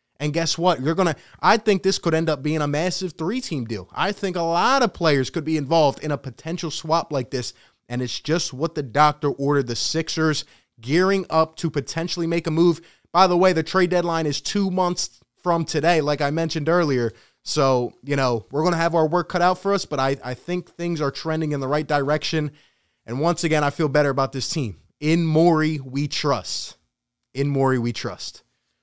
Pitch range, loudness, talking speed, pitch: 140-170 Hz, -22 LUFS, 215 wpm, 155 Hz